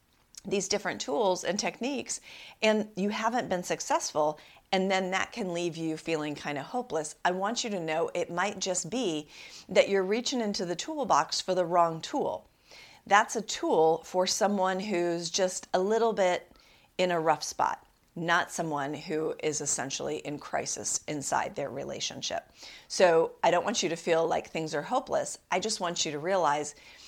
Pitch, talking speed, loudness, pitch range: 180 Hz, 175 wpm, -29 LUFS, 160-200 Hz